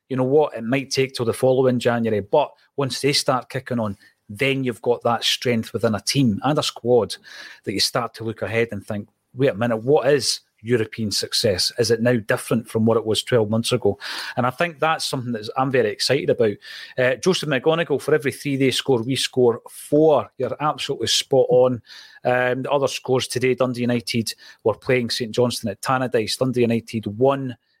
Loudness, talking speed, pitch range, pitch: -21 LUFS, 205 wpm, 115-130 Hz, 125 Hz